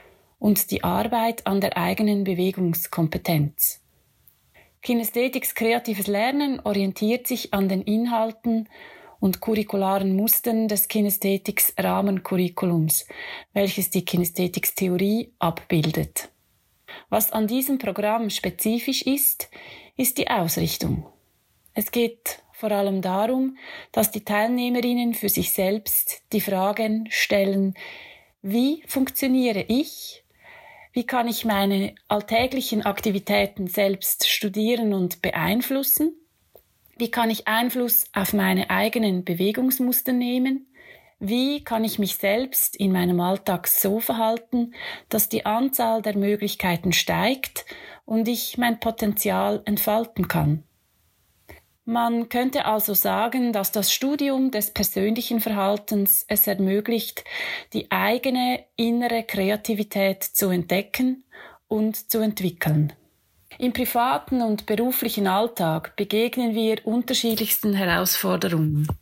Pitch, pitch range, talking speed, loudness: 215 Hz, 195-240 Hz, 105 wpm, -23 LUFS